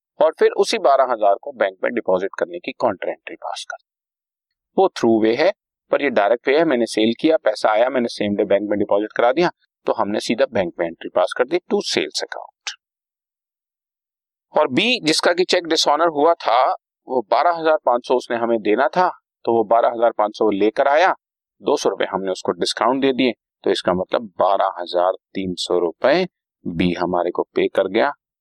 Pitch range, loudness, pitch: 105-165 Hz, -19 LUFS, 120 Hz